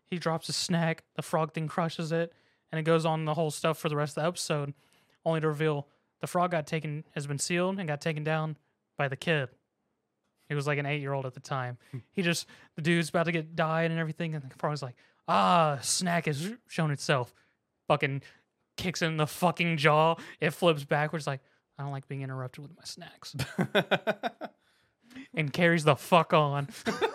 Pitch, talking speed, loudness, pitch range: 160 Hz, 200 wpm, -30 LUFS, 145-170 Hz